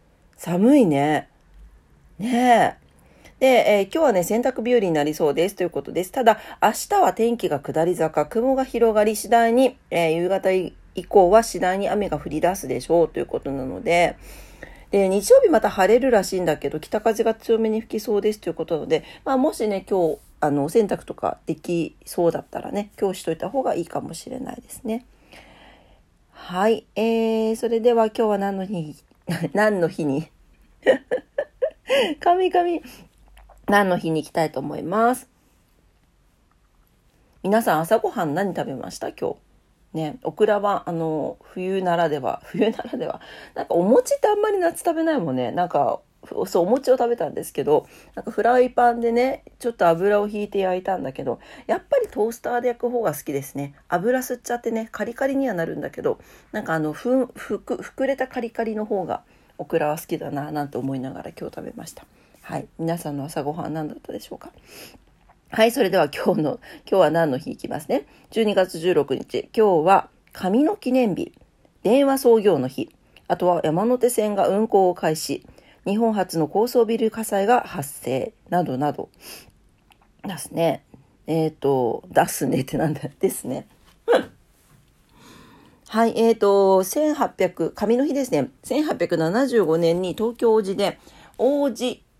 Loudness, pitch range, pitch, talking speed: -22 LUFS, 165-240 Hz, 205 Hz, 320 characters per minute